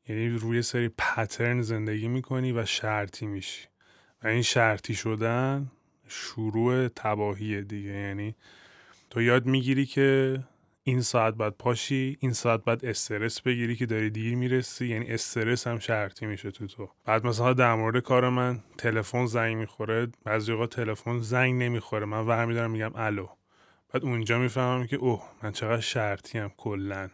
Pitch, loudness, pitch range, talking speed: 115 Hz, -28 LUFS, 110-125 Hz, 155 wpm